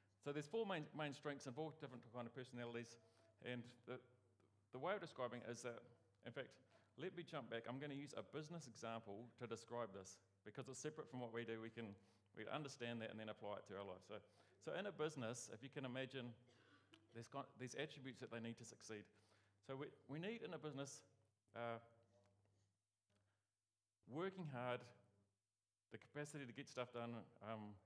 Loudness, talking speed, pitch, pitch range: -53 LUFS, 195 wpm, 120 Hz, 105-135 Hz